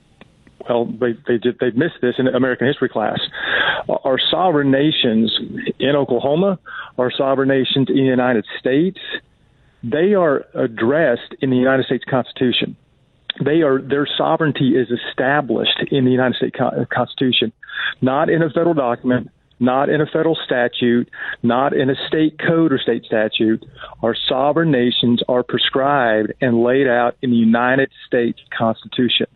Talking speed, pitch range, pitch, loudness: 145 wpm, 120-140 Hz, 130 Hz, -17 LUFS